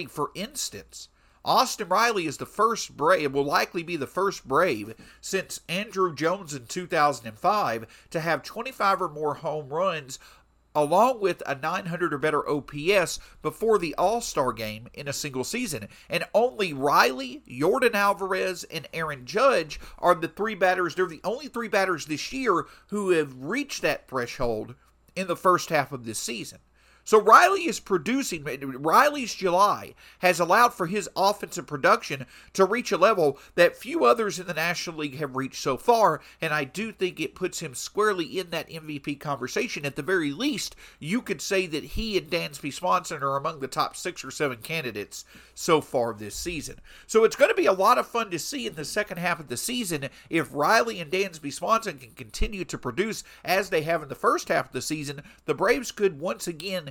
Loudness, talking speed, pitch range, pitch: -26 LUFS, 190 wpm, 145-195 Hz, 175 Hz